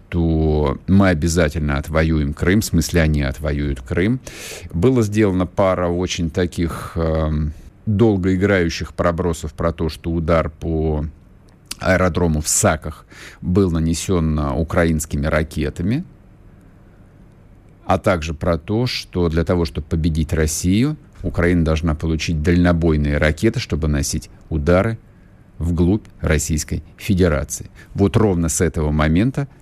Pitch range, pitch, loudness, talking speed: 80-95 Hz, 85 Hz, -19 LUFS, 115 wpm